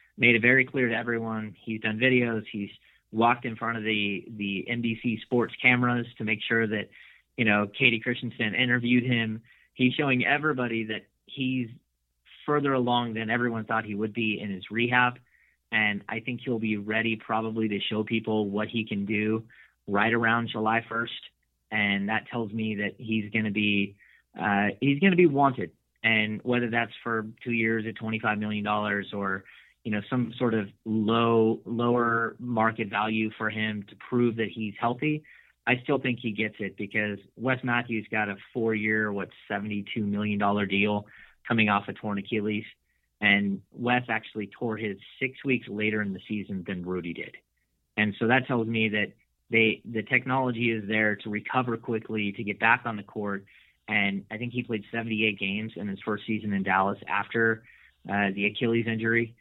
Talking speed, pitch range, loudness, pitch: 180 wpm, 105-120 Hz, -27 LUFS, 110 Hz